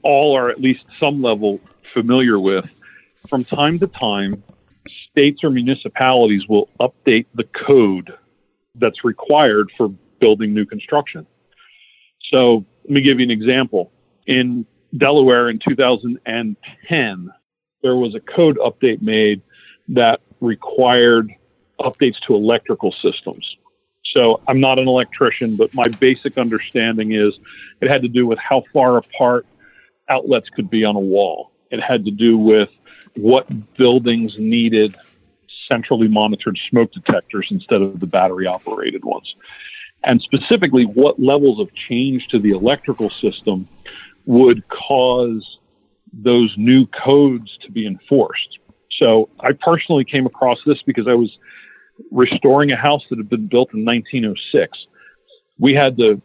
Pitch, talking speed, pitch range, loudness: 125 Hz, 140 wpm, 110-140 Hz, -16 LUFS